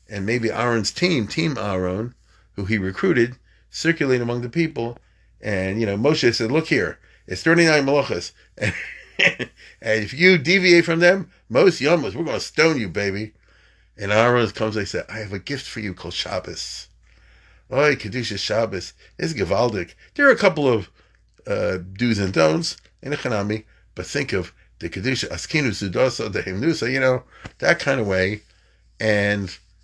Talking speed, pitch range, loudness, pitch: 165 wpm, 100-135 Hz, -21 LUFS, 110 Hz